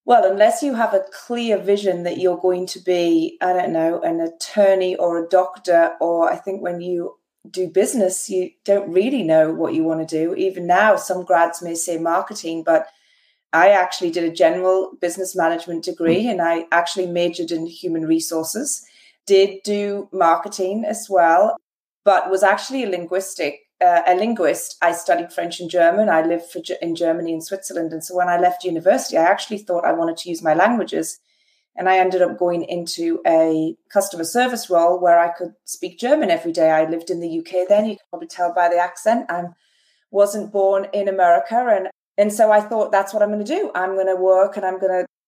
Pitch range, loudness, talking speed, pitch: 170-200 Hz, -19 LUFS, 205 wpm, 180 Hz